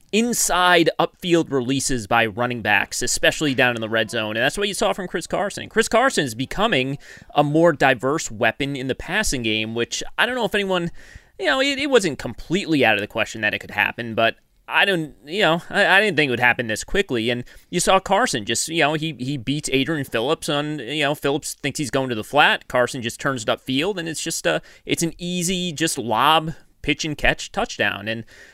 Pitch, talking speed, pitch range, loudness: 145 Hz, 225 wpm, 125-175 Hz, -20 LUFS